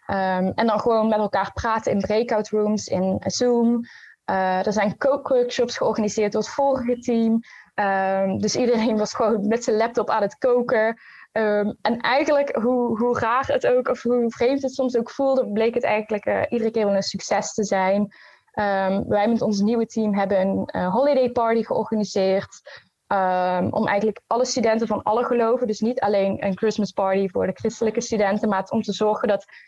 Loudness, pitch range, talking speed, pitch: -22 LUFS, 200-240 Hz, 190 wpm, 220 Hz